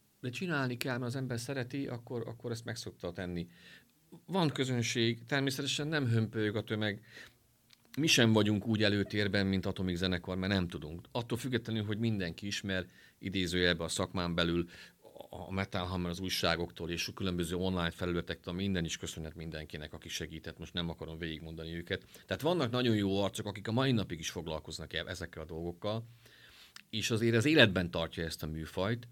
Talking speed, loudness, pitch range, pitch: 170 wpm, -34 LUFS, 85-115 Hz, 95 Hz